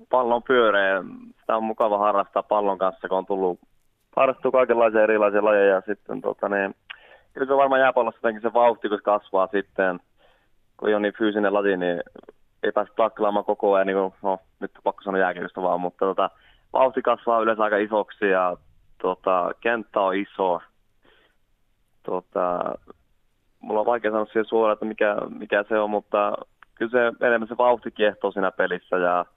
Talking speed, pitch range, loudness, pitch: 165 wpm, 95-115 Hz, -23 LUFS, 105 Hz